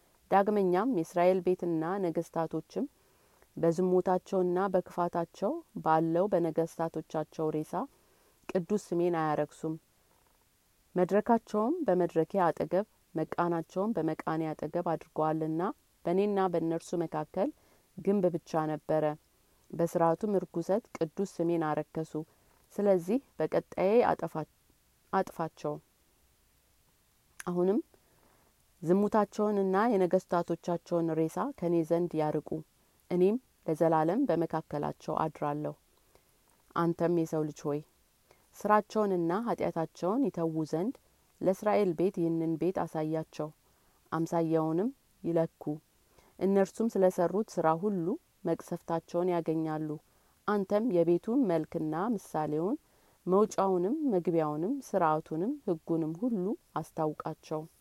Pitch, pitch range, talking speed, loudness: 170 Hz, 160-190 Hz, 80 wpm, -31 LUFS